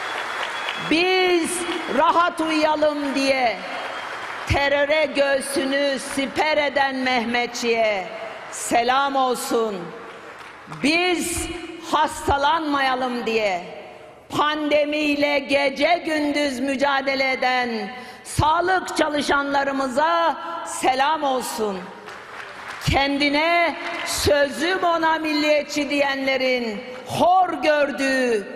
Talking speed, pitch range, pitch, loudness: 65 wpm, 265-320 Hz, 285 Hz, -21 LUFS